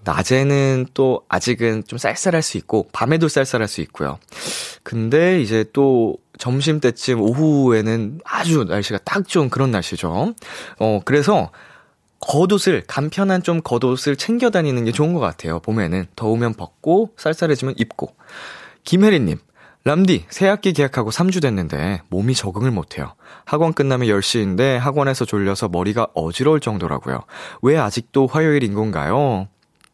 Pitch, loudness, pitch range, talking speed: 130 Hz, -18 LUFS, 105-155 Hz, 310 characters per minute